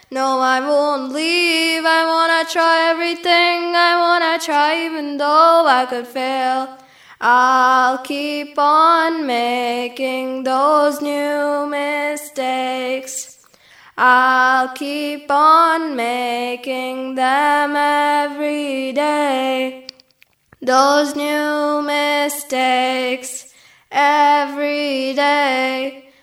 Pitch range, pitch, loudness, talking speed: 260-295 Hz, 290 Hz, -16 LUFS, 80 wpm